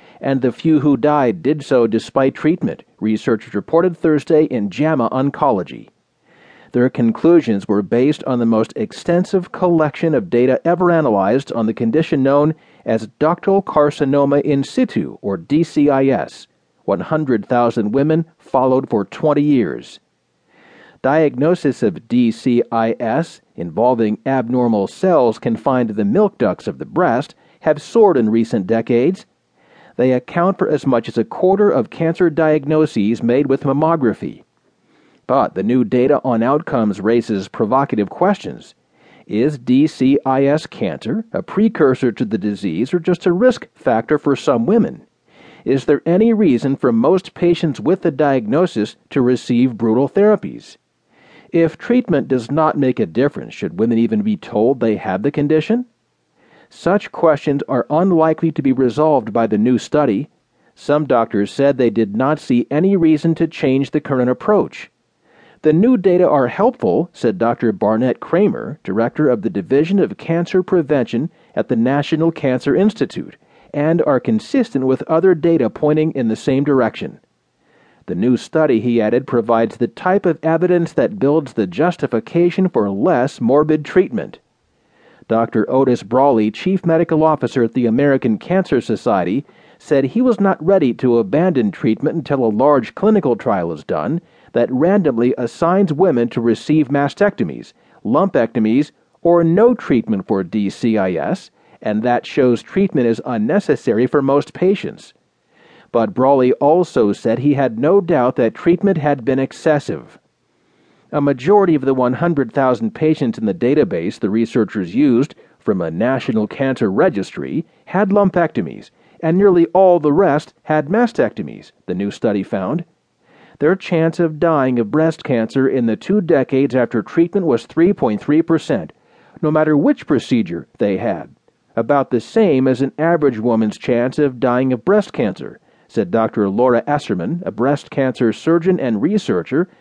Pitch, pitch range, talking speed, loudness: 145 Hz, 125-170 Hz, 145 wpm, -16 LUFS